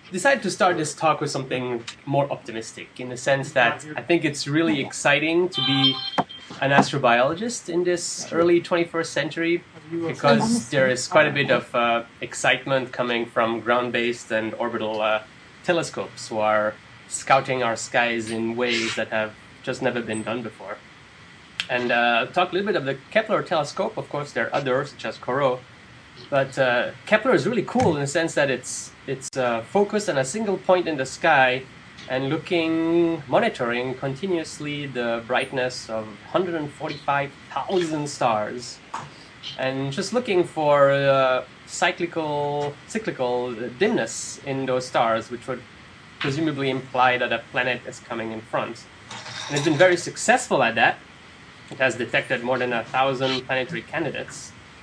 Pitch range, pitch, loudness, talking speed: 120-160 Hz, 135 Hz, -23 LUFS, 160 wpm